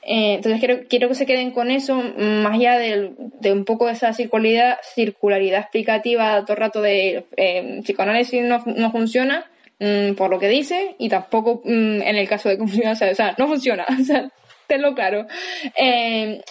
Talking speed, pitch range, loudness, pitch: 180 wpm, 210-245 Hz, -19 LUFS, 225 Hz